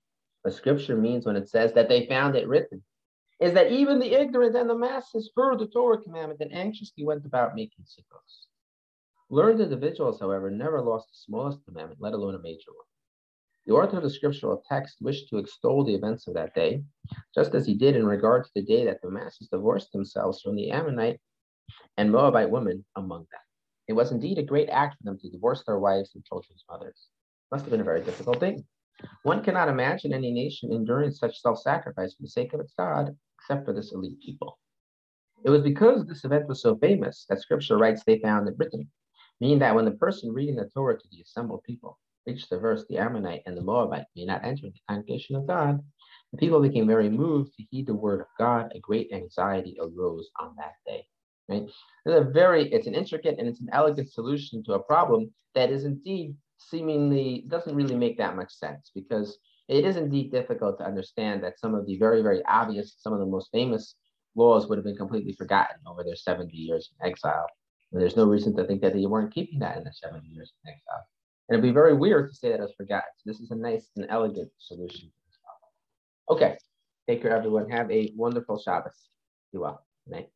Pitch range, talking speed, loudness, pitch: 105-155 Hz, 210 wpm, -26 LUFS, 125 Hz